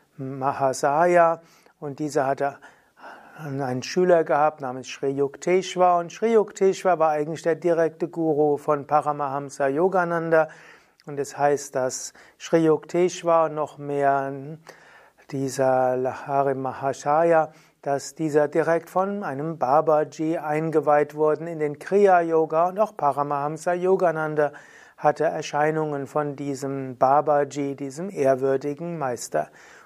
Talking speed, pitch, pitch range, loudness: 115 wpm, 150 Hz, 140-165 Hz, -23 LUFS